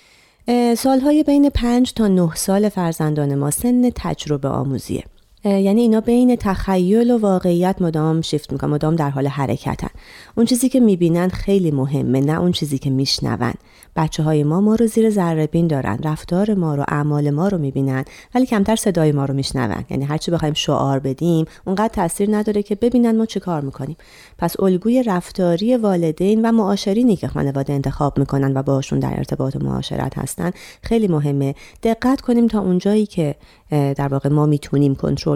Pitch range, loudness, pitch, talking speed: 140-210 Hz, -18 LUFS, 170 Hz, 170 wpm